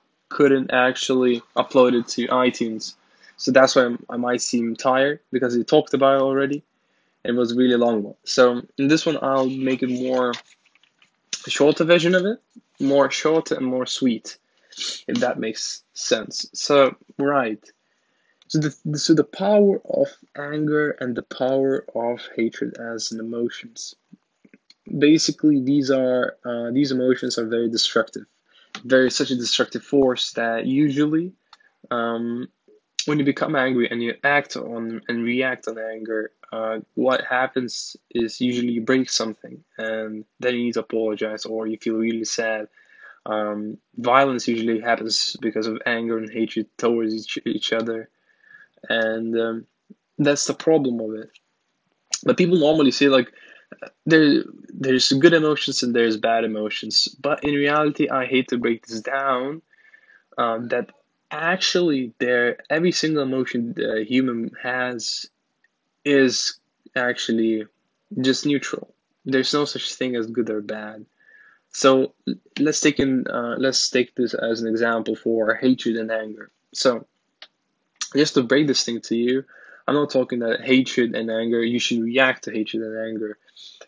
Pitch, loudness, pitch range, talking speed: 125 Hz, -21 LUFS, 115-145 Hz, 155 wpm